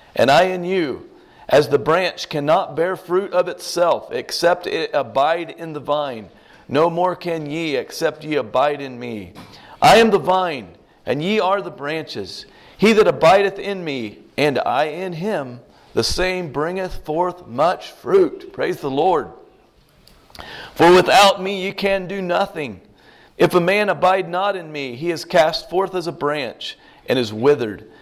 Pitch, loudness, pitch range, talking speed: 180 Hz, -18 LUFS, 155-195 Hz, 165 wpm